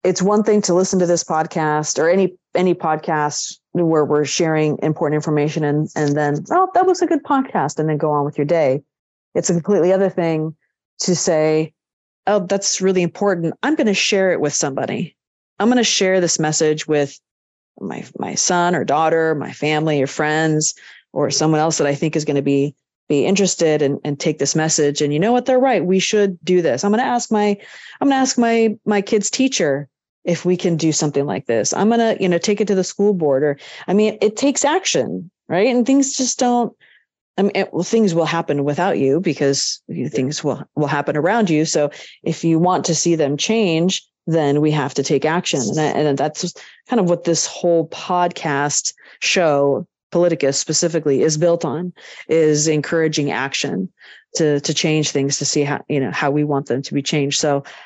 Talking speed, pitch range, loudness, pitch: 205 wpm, 150-195 Hz, -18 LUFS, 165 Hz